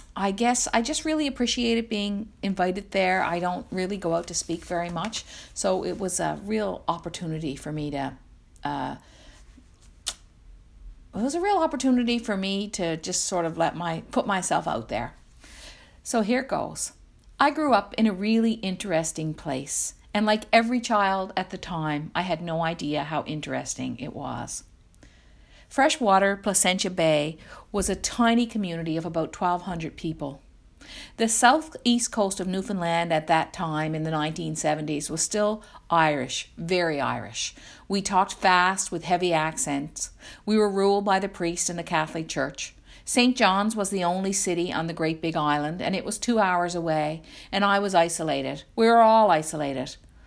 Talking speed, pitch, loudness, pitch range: 165 wpm, 185 Hz, -25 LUFS, 160-210 Hz